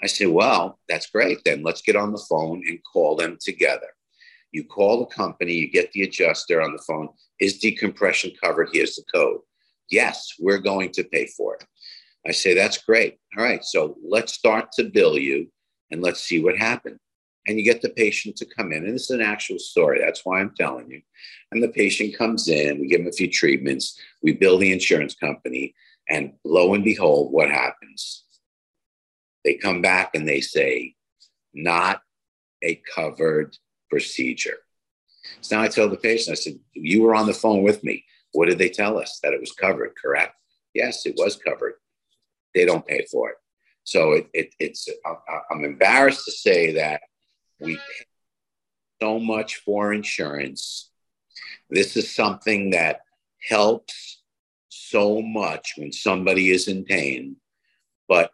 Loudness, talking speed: -21 LUFS, 175 wpm